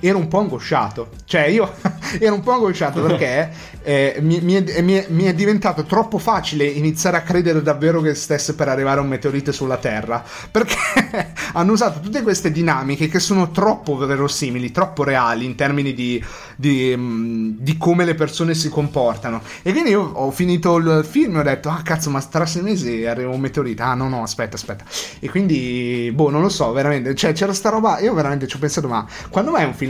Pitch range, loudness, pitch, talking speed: 135-180 Hz, -18 LUFS, 150 Hz, 205 wpm